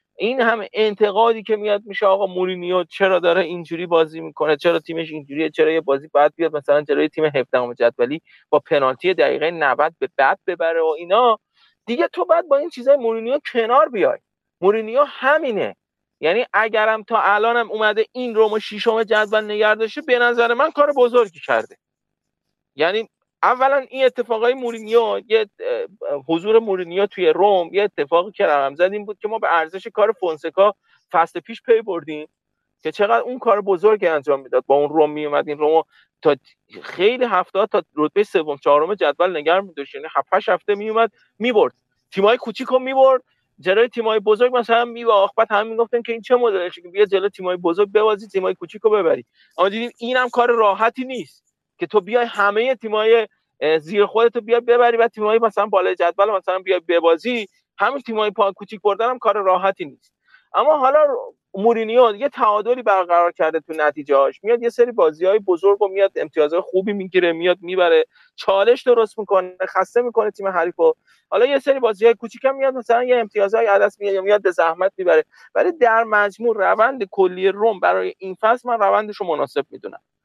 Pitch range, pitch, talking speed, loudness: 180-240 Hz, 215 Hz, 175 wpm, -18 LUFS